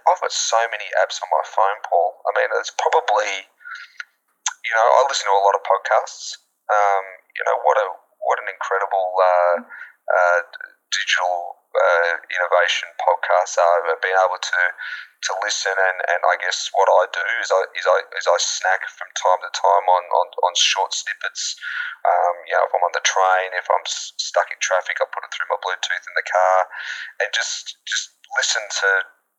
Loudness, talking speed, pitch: -20 LUFS, 190 wpm, 100 Hz